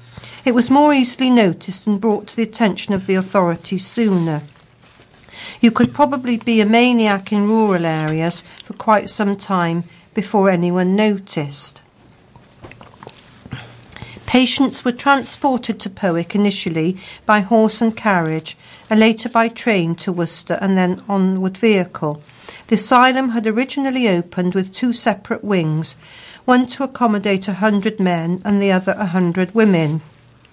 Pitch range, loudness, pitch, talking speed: 175-230 Hz, -16 LUFS, 205 Hz, 140 wpm